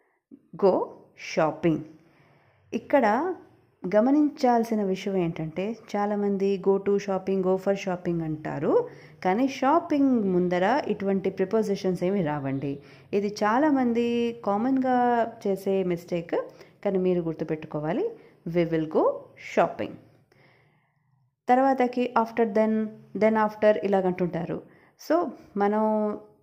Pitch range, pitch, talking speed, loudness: 175-235 Hz, 200 Hz, 95 wpm, -26 LUFS